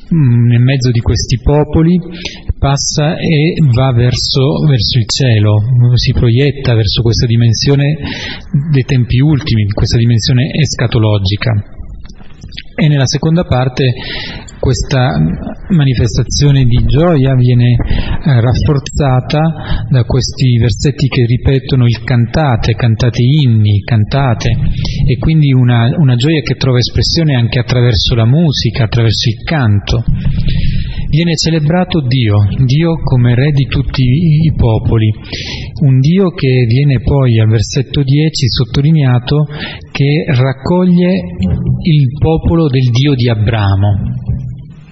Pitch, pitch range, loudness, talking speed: 130 Hz, 120-145 Hz, -11 LUFS, 115 wpm